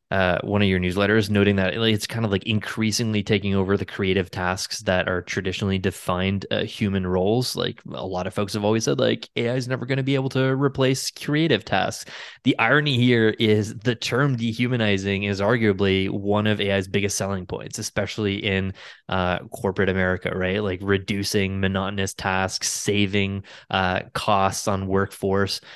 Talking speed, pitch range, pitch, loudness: 170 wpm, 95-115 Hz, 100 Hz, -23 LUFS